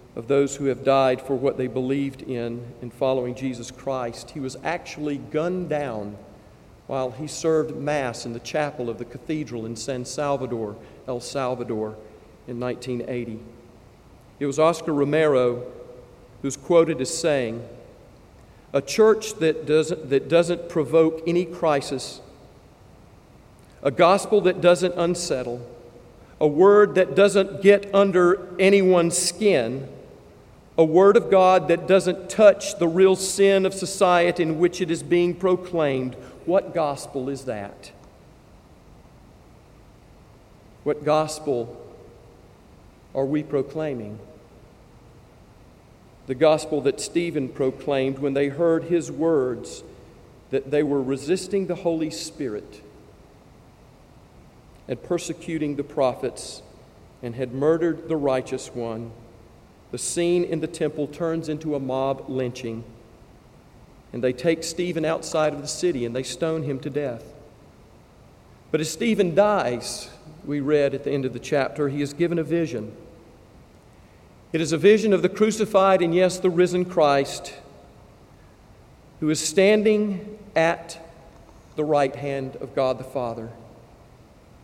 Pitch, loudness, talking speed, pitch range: 145 Hz, -22 LUFS, 130 wpm, 125-170 Hz